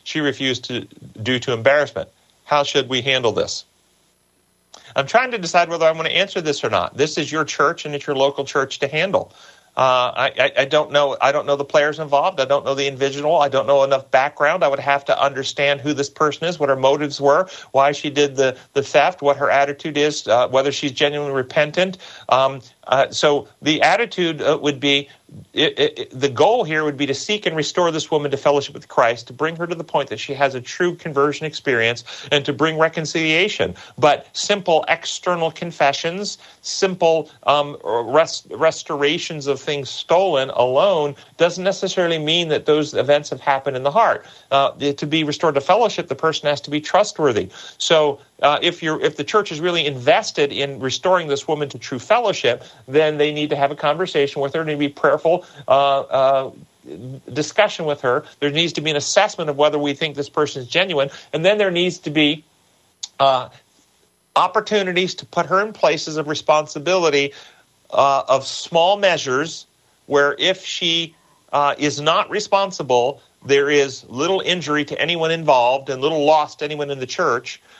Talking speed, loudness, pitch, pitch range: 200 wpm, -19 LUFS, 150 Hz, 140-165 Hz